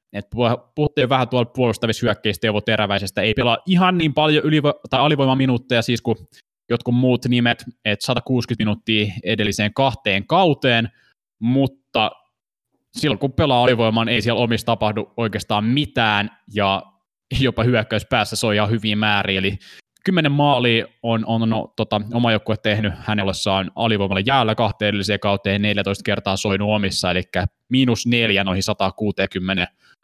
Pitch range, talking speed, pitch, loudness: 105-125 Hz, 140 wpm, 115 Hz, -19 LUFS